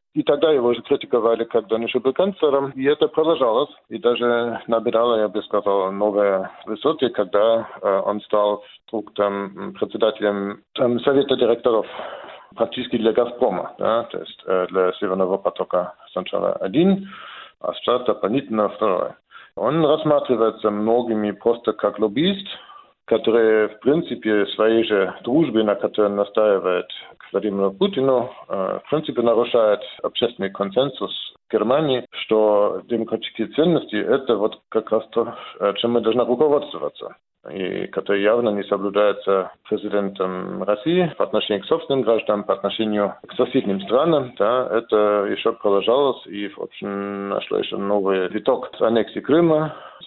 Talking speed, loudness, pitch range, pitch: 135 wpm, -21 LUFS, 100-125 Hz, 110 Hz